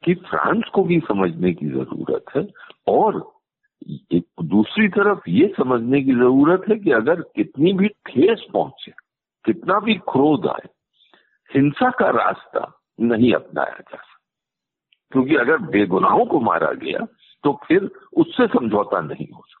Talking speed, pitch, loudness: 140 wpm, 175 Hz, -19 LUFS